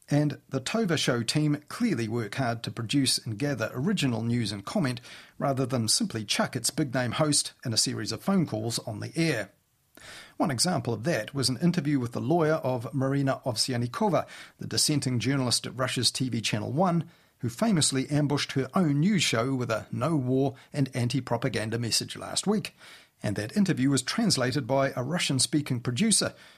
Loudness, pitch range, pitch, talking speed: -27 LUFS, 120-155 Hz, 135 Hz, 185 wpm